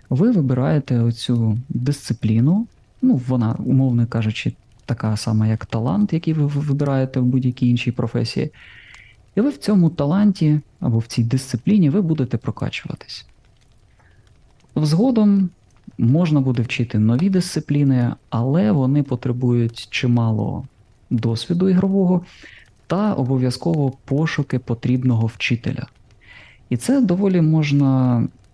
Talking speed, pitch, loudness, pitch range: 110 wpm, 130 Hz, -19 LUFS, 120-160 Hz